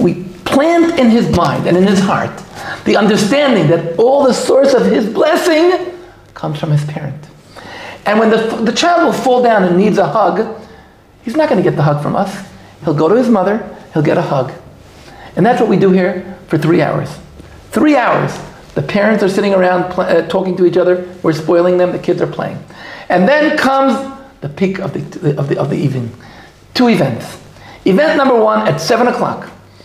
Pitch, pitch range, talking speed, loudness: 190 Hz, 170-240 Hz, 200 wpm, -13 LUFS